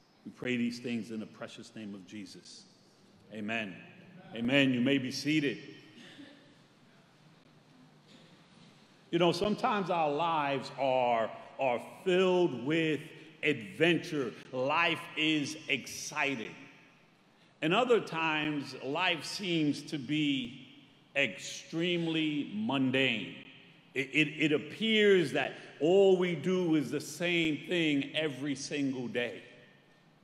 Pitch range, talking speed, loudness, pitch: 135-170 Hz, 105 wpm, -31 LUFS, 150 Hz